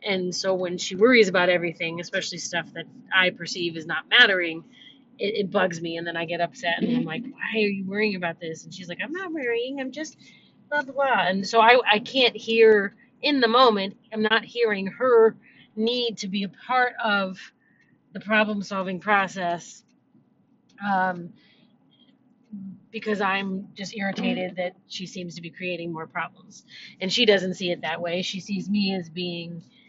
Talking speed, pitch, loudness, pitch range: 185 wpm, 200 Hz, -23 LUFS, 180-230 Hz